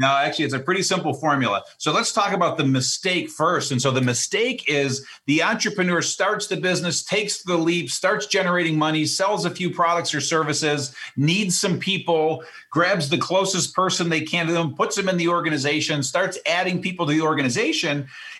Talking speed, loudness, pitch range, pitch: 190 wpm, -21 LUFS, 150-185 Hz, 170 Hz